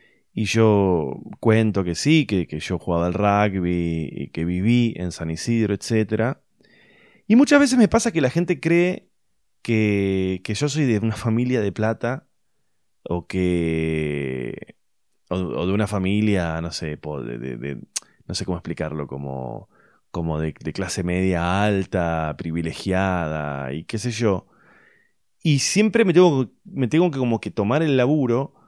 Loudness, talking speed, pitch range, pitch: -22 LUFS, 155 wpm, 85-130 Hz, 105 Hz